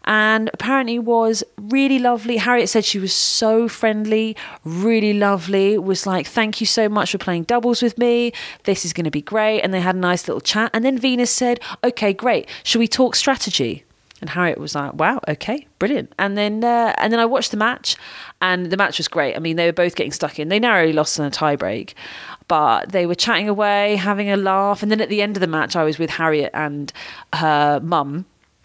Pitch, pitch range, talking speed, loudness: 205 Hz, 175-230 Hz, 220 wpm, -18 LUFS